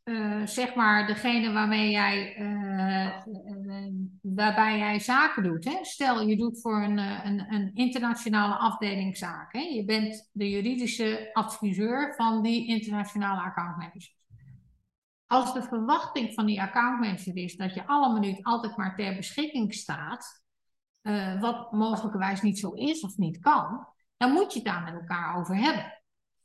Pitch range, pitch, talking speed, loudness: 195-235 Hz, 210 Hz, 160 wpm, -28 LUFS